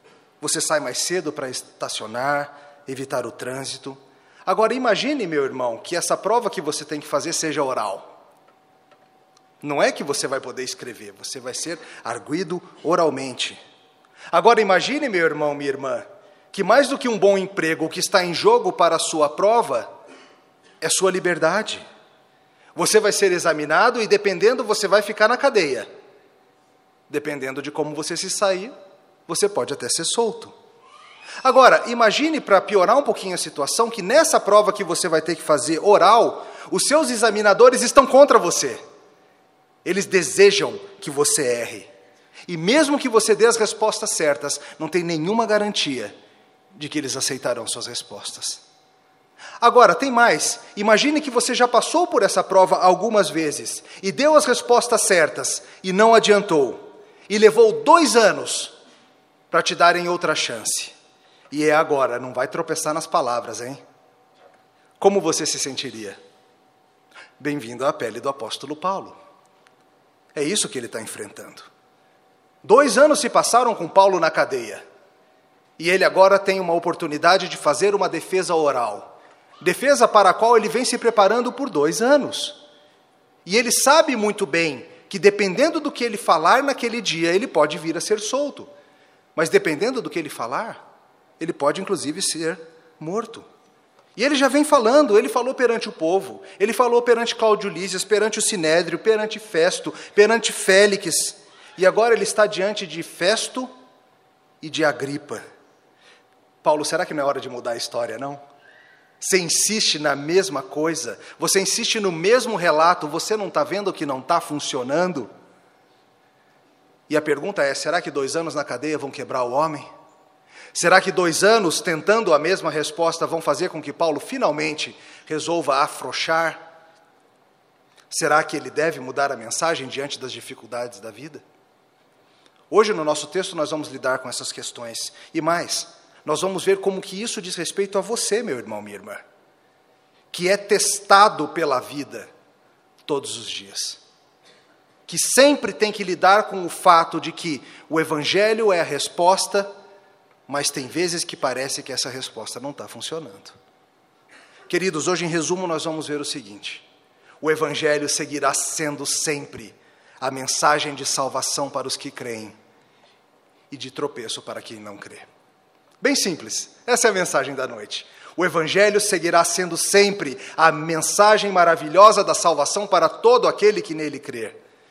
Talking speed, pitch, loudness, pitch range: 160 wpm, 180 Hz, -19 LUFS, 150-215 Hz